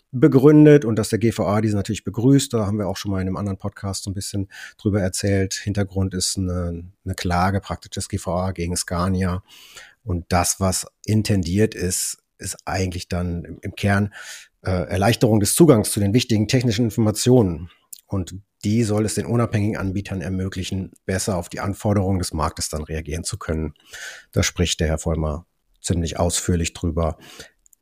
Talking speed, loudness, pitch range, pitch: 170 wpm, -21 LUFS, 90-105 Hz, 95 Hz